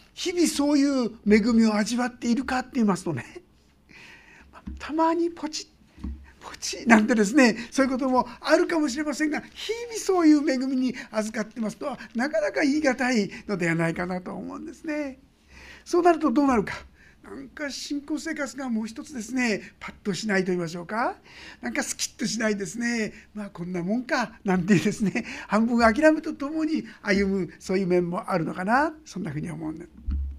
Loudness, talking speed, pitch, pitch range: -25 LUFS, 380 characters per minute, 240 Hz, 205-290 Hz